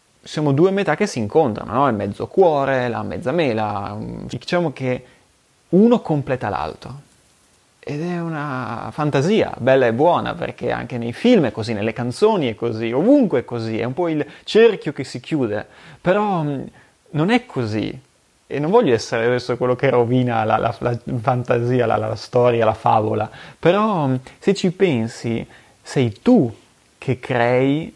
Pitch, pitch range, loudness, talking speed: 130 Hz, 115-165 Hz, -19 LUFS, 160 wpm